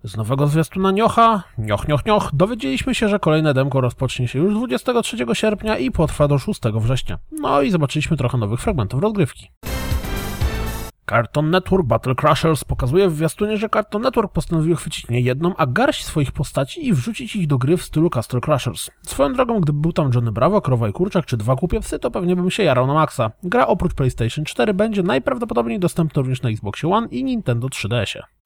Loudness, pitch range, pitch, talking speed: -19 LUFS, 130-205 Hz, 155 Hz, 190 wpm